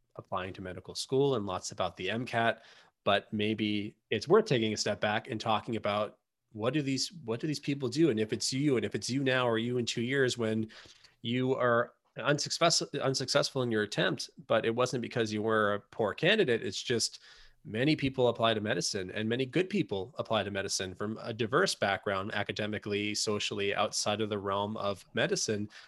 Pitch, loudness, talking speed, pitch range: 110 Hz, -31 LUFS, 195 wpm, 105-125 Hz